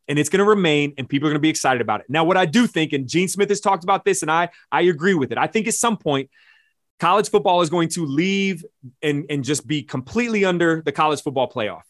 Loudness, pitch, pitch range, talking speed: -20 LUFS, 170 Hz, 150-195 Hz, 265 wpm